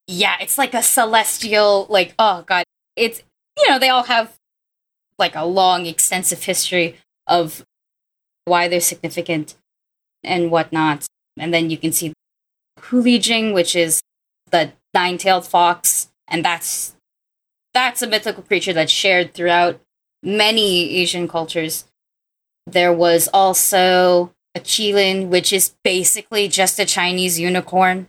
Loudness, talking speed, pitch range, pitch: -16 LUFS, 130 wpm, 175-205 Hz, 180 Hz